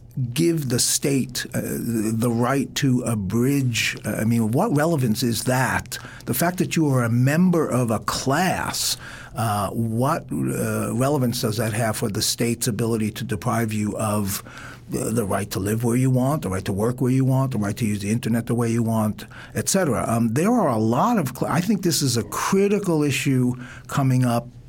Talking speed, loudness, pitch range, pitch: 205 wpm, -22 LUFS, 110-135 Hz, 120 Hz